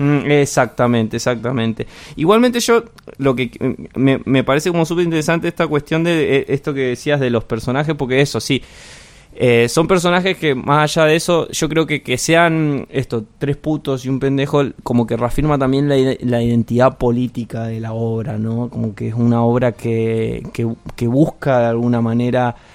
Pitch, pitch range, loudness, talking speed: 130 Hz, 120-150 Hz, -17 LUFS, 180 wpm